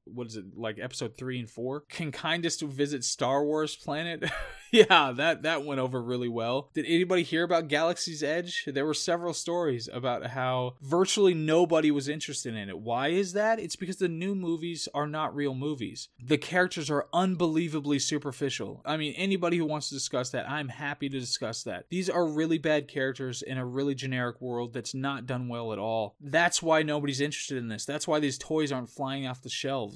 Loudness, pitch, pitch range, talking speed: -29 LUFS, 145 Hz, 130-165 Hz, 200 wpm